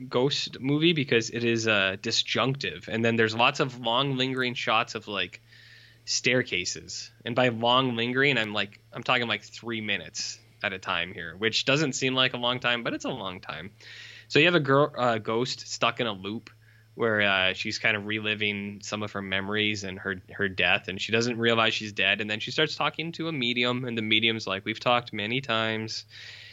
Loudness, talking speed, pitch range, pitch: -26 LUFS, 210 wpm, 105-125 Hz, 115 Hz